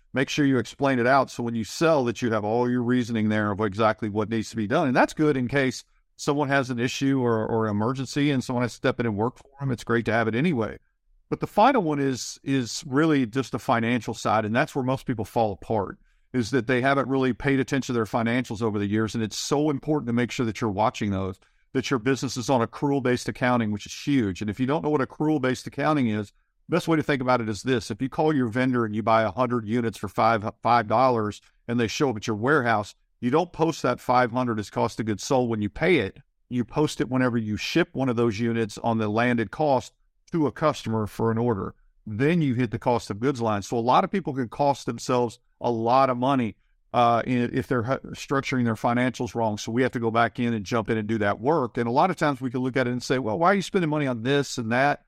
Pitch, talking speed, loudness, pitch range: 125 Hz, 265 wpm, -25 LUFS, 115-135 Hz